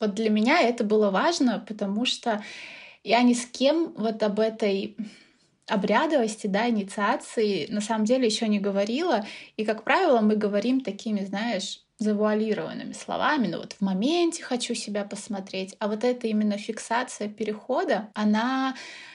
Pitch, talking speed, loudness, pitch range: 220 Hz, 145 wpm, -26 LUFS, 210-250 Hz